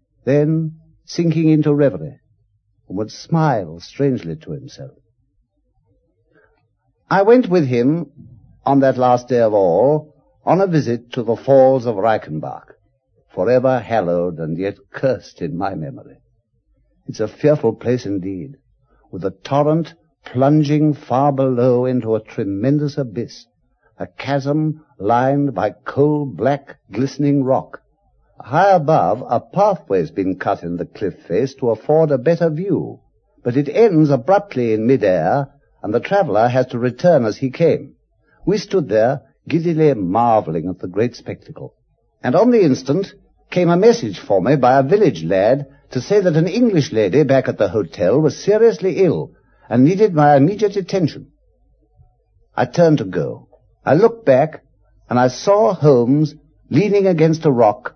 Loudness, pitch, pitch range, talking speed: -17 LUFS, 140 Hz, 120-155 Hz, 150 wpm